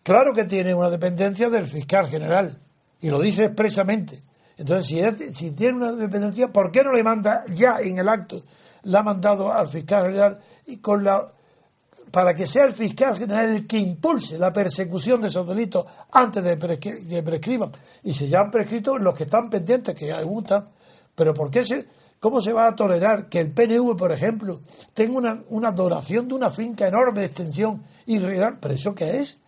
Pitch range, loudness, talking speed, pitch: 180-230 Hz, -22 LUFS, 205 wpm, 205 Hz